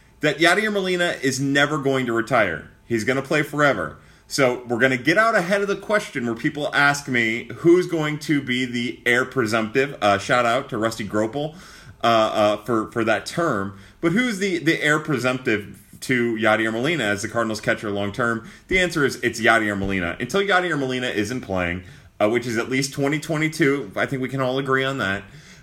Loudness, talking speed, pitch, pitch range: -21 LUFS, 200 wpm, 130 Hz, 115-150 Hz